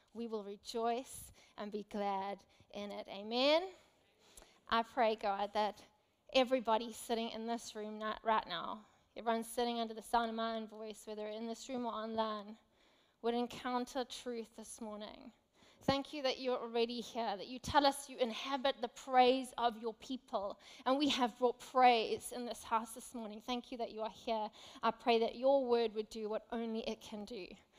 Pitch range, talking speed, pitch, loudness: 220-250 Hz, 185 wpm, 230 Hz, -38 LUFS